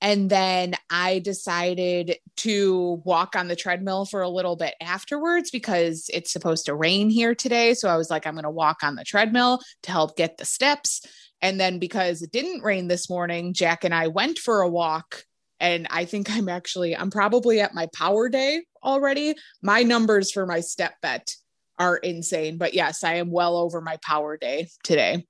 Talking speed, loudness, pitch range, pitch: 195 wpm, -23 LUFS, 170-205 Hz, 180 Hz